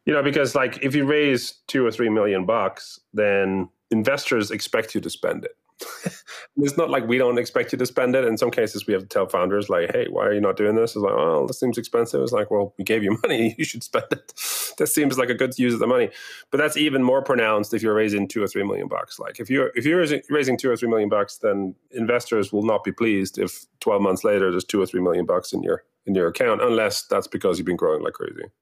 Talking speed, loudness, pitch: 260 wpm, -22 LUFS, 130 Hz